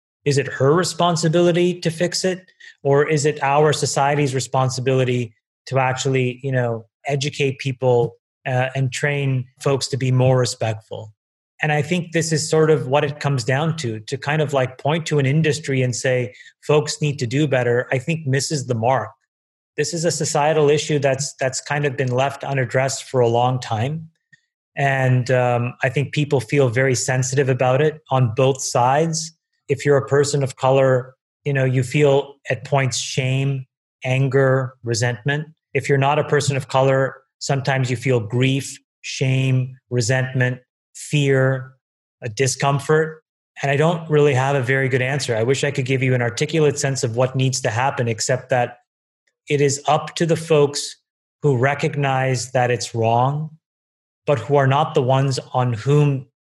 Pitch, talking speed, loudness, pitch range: 135 Hz, 175 wpm, -19 LUFS, 130-145 Hz